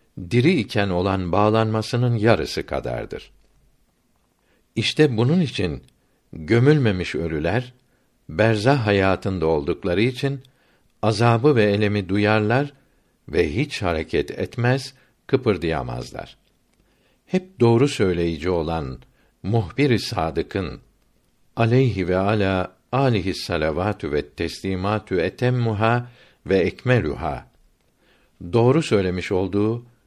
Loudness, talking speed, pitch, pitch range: -21 LUFS, 85 wpm, 110 Hz, 95-125 Hz